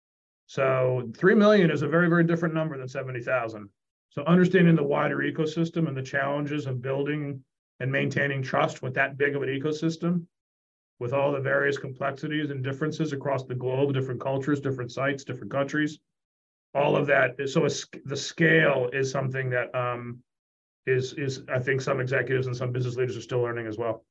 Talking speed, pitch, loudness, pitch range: 180 wpm, 135 Hz, -26 LUFS, 130-150 Hz